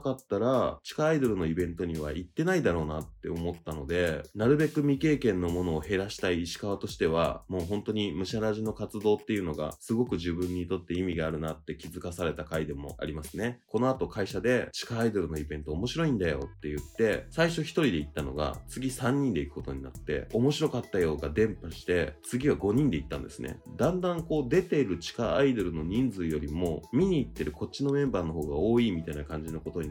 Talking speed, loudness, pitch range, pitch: 440 characters per minute, -30 LUFS, 80-120 Hz, 90 Hz